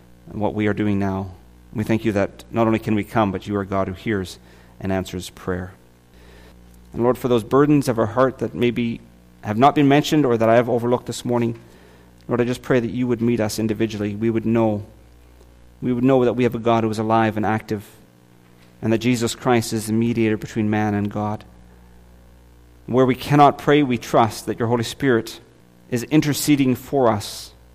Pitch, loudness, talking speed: 110 Hz, -20 LUFS, 210 wpm